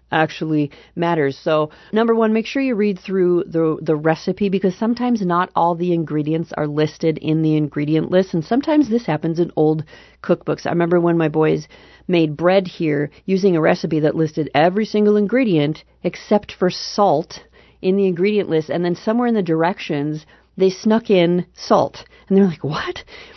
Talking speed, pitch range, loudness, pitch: 175 wpm, 155-200 Hz, -18 LUFS, 175 Hz